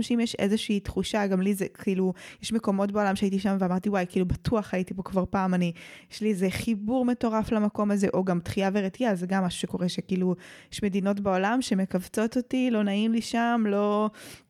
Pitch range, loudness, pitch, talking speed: 190-220 Hz, -27 LUFS, 200 Hz, 200 wpm